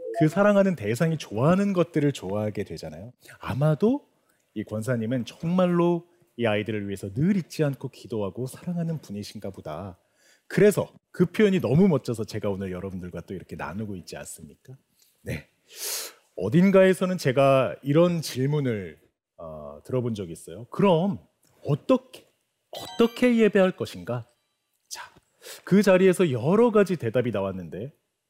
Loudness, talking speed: -24 LUFS, 315 characters per minute